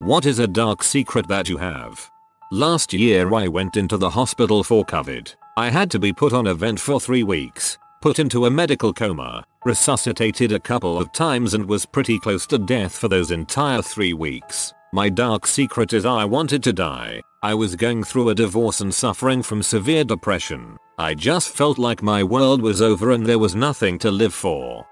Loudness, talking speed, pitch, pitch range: -19 LUFS, 200 wpm, 115 Hz, 100-130 Hz